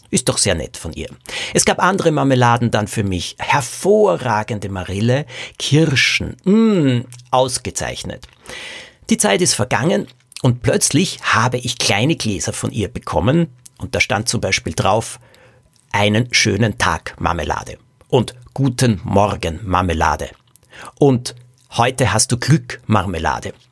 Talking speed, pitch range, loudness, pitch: 130 wpm, 105-135 Hz, -17 LUFS, 125 Hz